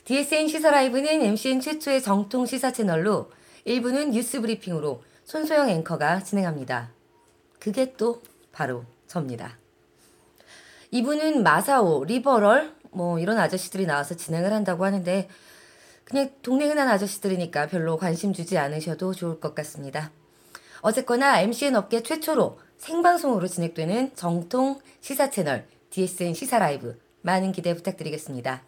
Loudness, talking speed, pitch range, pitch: -25 LUFS, 325 characters per minute, 160-260 Hz, 195 Hz